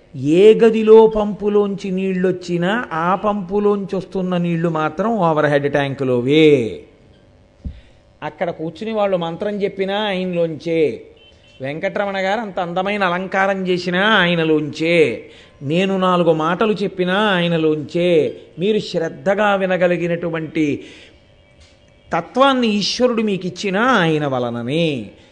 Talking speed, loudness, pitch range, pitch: 90 wpm, -17 LUFS, 165-205 Hz, 185 Hz